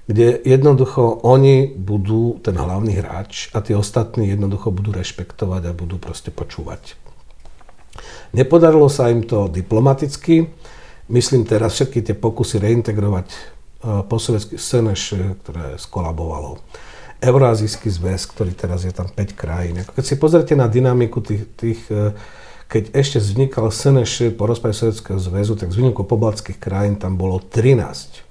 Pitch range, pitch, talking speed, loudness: 95-120 Hz, 110 Hz, 140 wpm, -17 LUFS